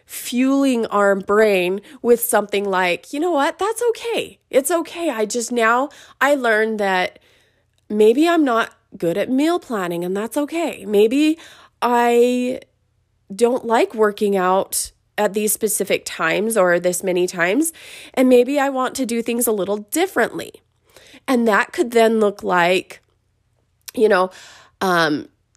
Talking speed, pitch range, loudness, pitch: 145 wpm, 195-275 Hz, -18 LUFS, 225 Hz